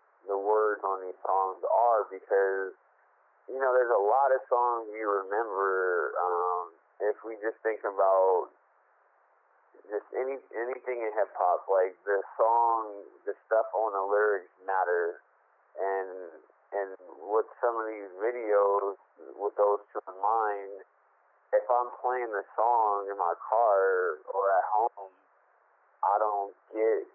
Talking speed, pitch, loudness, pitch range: 140 wpm, 105 Hz, -29 LUFS, 95-115 Hz